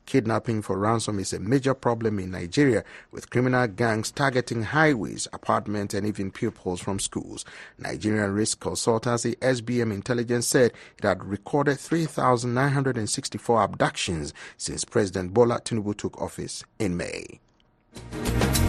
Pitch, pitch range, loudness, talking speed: 115 Hz, 105-125 Hz, -26 LUFS, 125 wpm